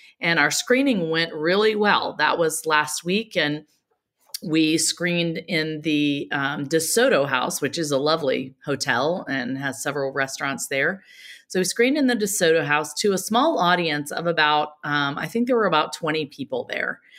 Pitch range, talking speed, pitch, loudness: 150-185 Hz, 175 wpm, 160 Hz, -22 LUFS